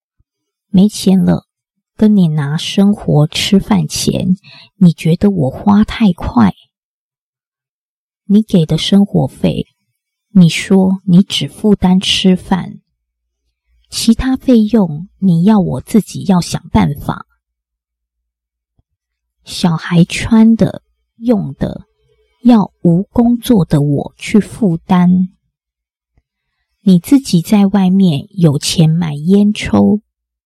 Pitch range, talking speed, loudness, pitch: 140-205 Hz, 140 characters per minute, -12 LUFS, 180 Hz